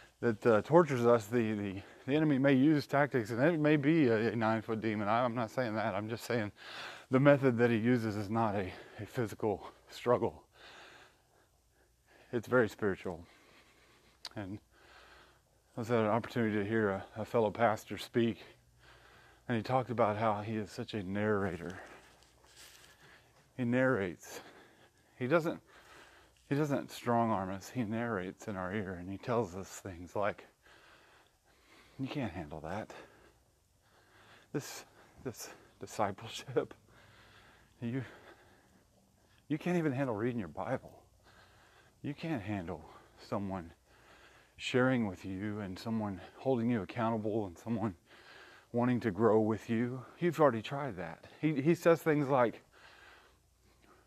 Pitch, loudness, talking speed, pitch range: 115 Hz, -34 LUFS, 140 wpm, 105-130 Hz